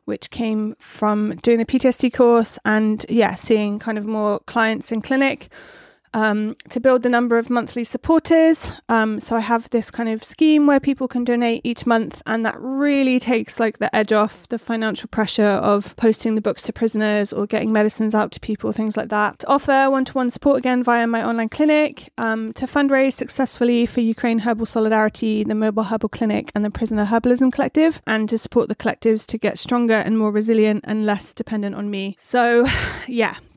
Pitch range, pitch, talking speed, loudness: 215-250 Hz, 230 Hz, 195 wpm, -19 LUFS